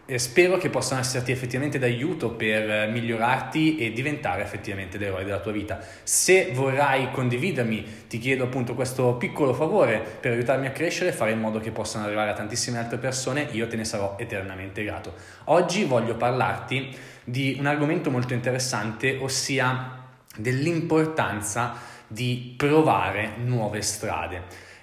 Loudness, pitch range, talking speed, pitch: -25 LUFS, 110-130 Hz, 145 wpm, 125 Hz